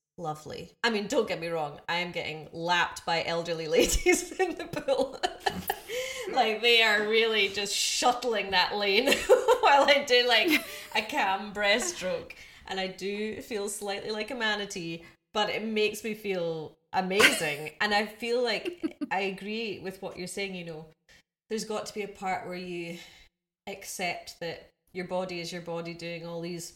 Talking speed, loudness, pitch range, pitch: 170 wpm, -28 LUFS, 175-235 Hz, 200 Hz